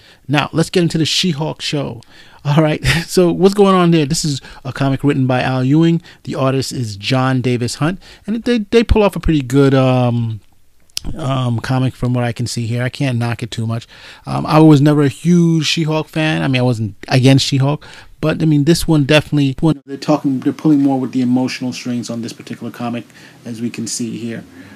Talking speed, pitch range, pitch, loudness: 215 wpm, 125-155 Hz, 135 Hz, -15 LUFS